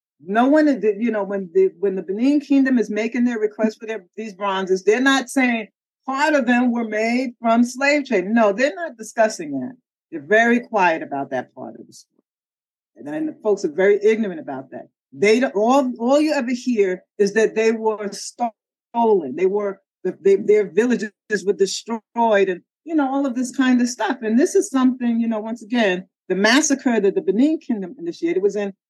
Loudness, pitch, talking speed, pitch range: -19 LUFS, 225 Hz, 200 wpm, 205-265 Hz